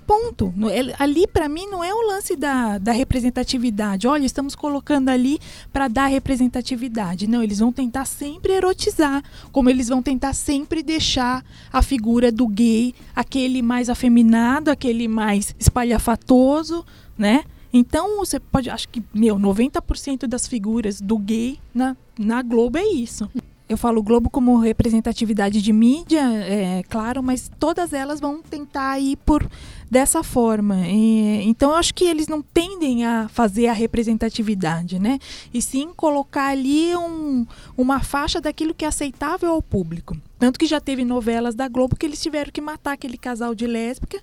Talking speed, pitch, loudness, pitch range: 160 wpm, 255 Hz, -20 LUFS, 230-295 Hz